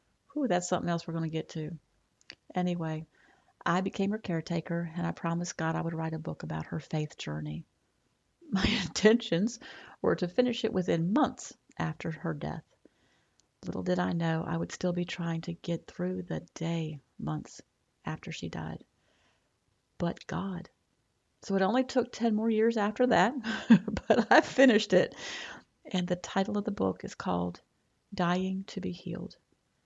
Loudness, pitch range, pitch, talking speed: -31 LUFS, 165-210 Hz, 180 Hz, 165 wpm